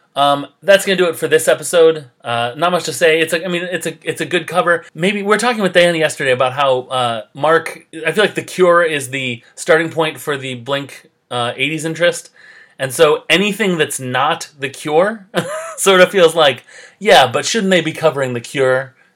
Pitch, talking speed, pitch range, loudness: 160 Hz, 215 wpm, 140-180 Hz, -15 LUFS